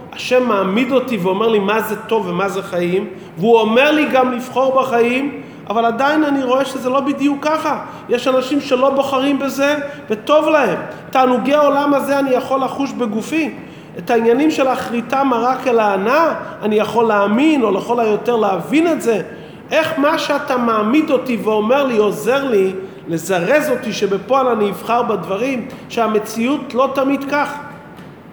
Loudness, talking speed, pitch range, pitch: -16 LUFS, 155 wpm, 220-280 Hz, 255 Hz